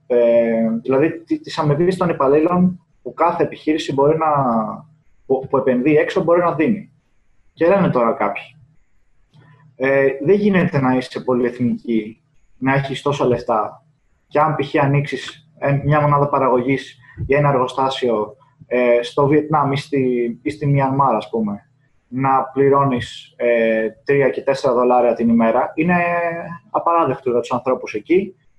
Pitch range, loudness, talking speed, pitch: 125-150 Hz, -18 LUFS, 140 wpm, 140 Hz